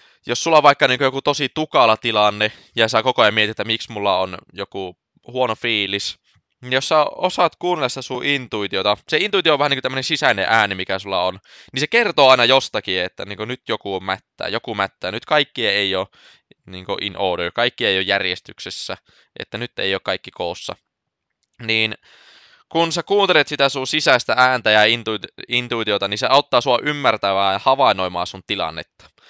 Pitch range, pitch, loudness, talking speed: 100-140 Hz, 120 Hz, -18 LUFS, 185 wpm